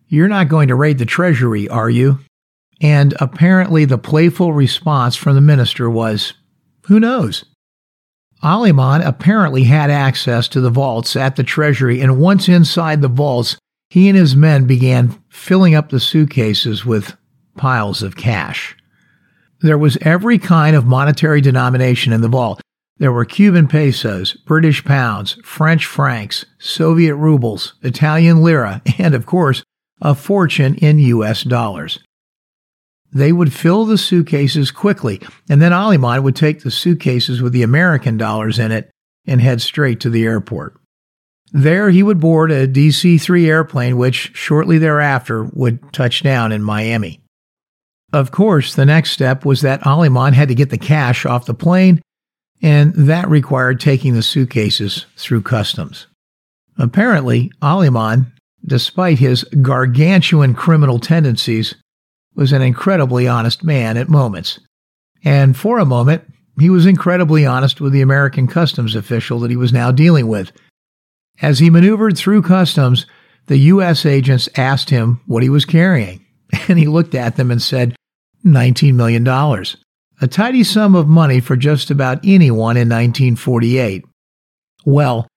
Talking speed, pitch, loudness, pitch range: 150 wpm, 140 Hz, -13 LUFS, 125-160 Hz